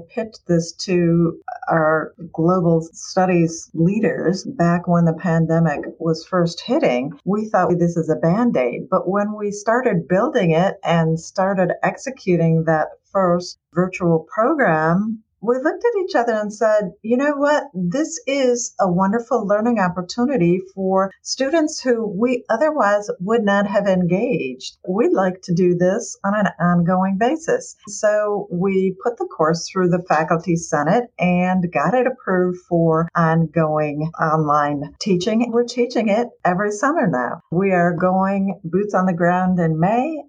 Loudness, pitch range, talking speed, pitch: -19 LUFS, 170-225 Hz, 150 wpm, 185 Hz